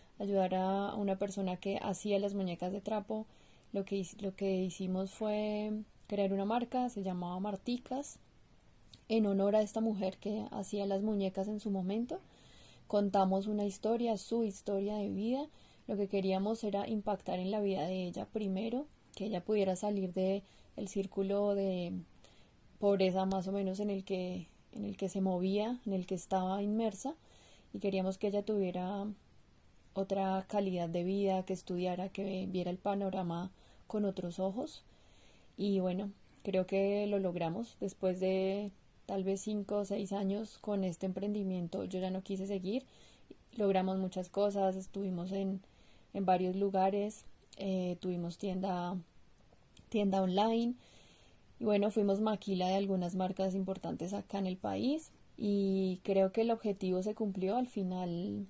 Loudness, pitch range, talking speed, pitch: -36 LUFS, 190-205 Hz, 155 wpm, 195 Hz